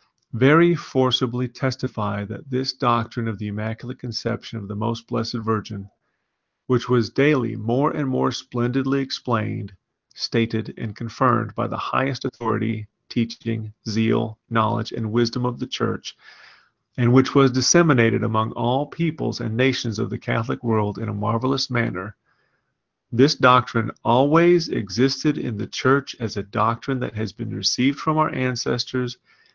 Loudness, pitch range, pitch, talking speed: -22 LUFS, 110-130 Hz, 120 Hz, 145 wpm